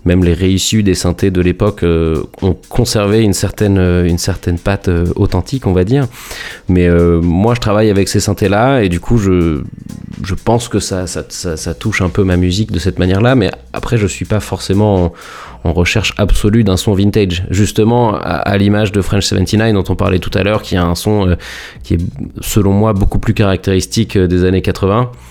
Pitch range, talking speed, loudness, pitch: 90-105 Hz, 215 wpm, -13 LUFS, 100 Hz